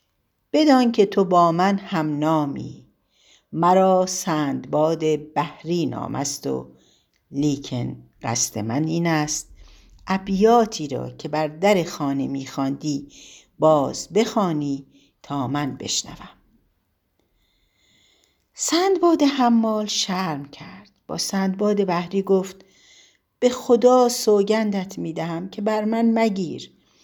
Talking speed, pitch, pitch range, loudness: 100 wpm, 175 Hz, 145-210 Hz, -21 LUFS